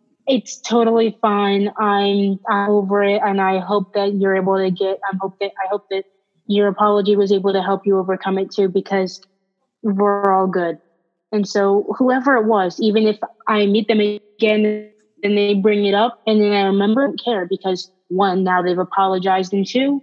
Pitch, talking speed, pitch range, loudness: 200 Hz, 195 wpm, 195-215 Hz, -18 LUFS